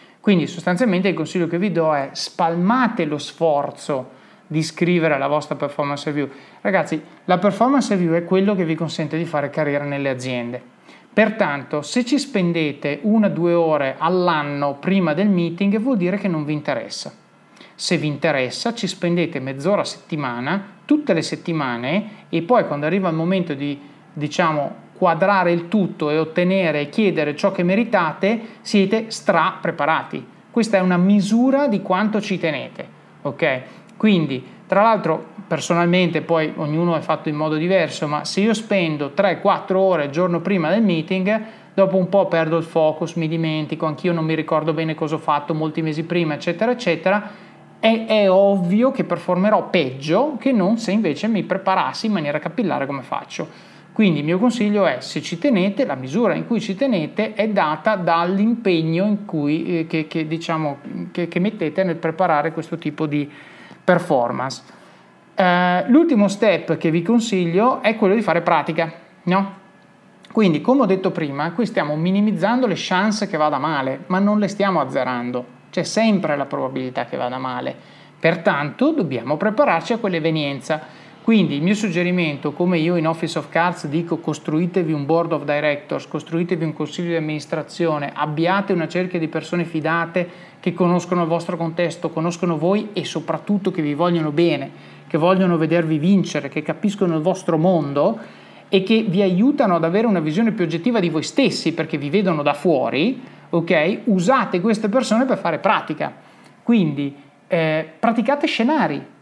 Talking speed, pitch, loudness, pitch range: 165 wpm, 175 Hz, -20 LUFS, 155-200 Hz